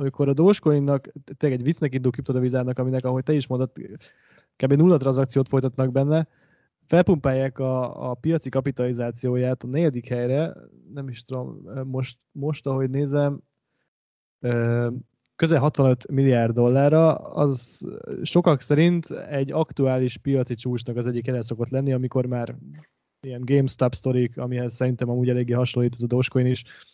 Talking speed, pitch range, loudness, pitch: 140 wpm, 125-145 Hz, -23 LUFS, 130 Hz